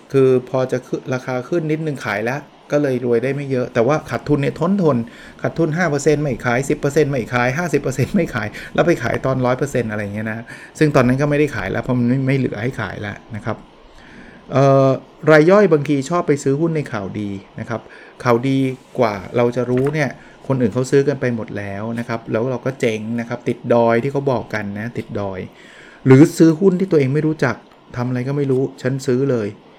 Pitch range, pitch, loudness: 120-145 Hz, 130 Hz, -18 LUFS